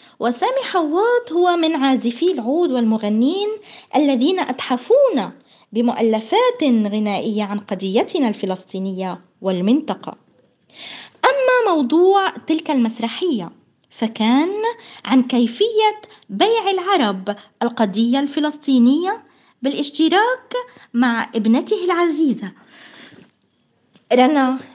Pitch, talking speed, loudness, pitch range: 275 Hz, 75 wpm, -18 LUFS, 230-365 Hz